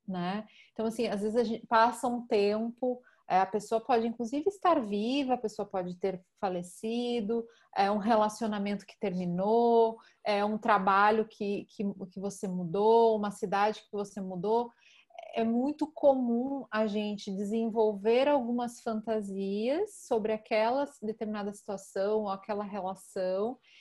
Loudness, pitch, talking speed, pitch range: -31 LUFS, 220 Hz, 140 wpm, 205-235 Hz